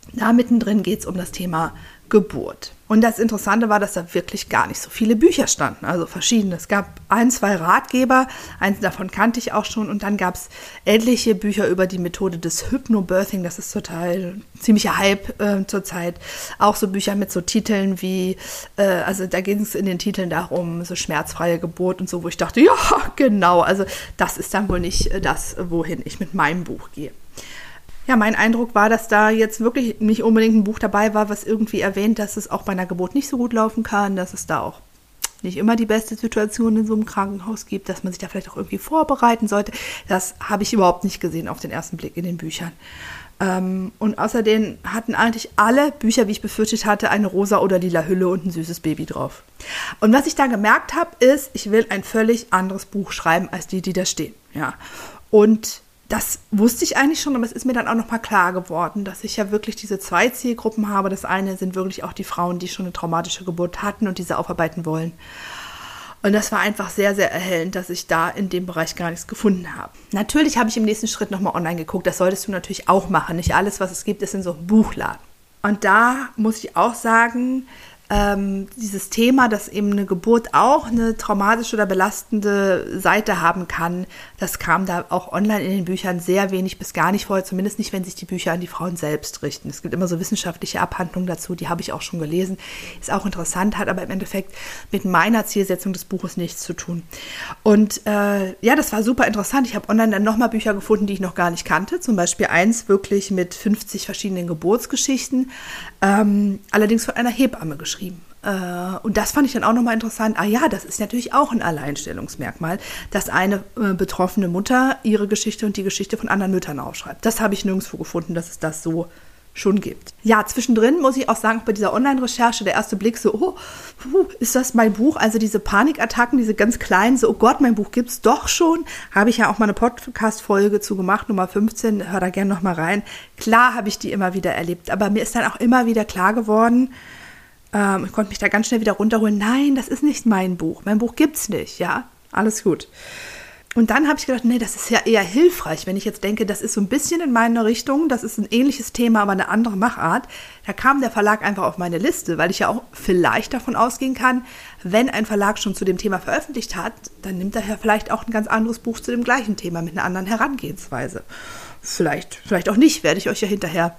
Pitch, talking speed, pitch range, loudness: 205 Hz, 220 wpm, 185-225 Hz, -19 LUFS